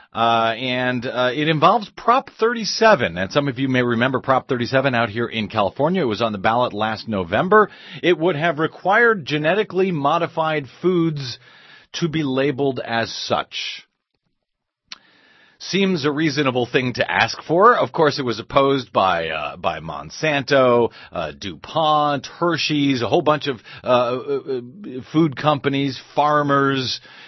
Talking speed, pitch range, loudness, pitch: 145 wpm, 125-160 Hz, -19 LUFS, 140 Hz